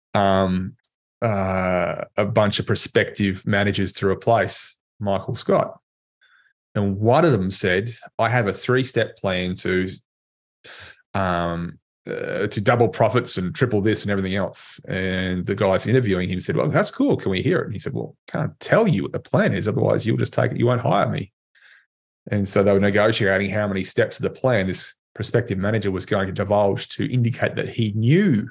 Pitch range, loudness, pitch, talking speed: 95-110 Hz, -21 LUFS, 100 Hz, 190 wpm